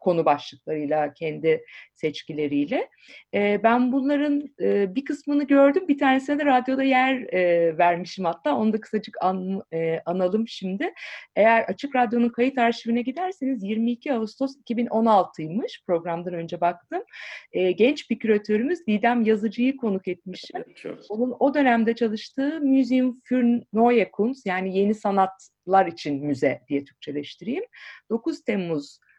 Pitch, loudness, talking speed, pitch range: 225 Hz, -24 LUFS, 130 wpm, 180-265 Hz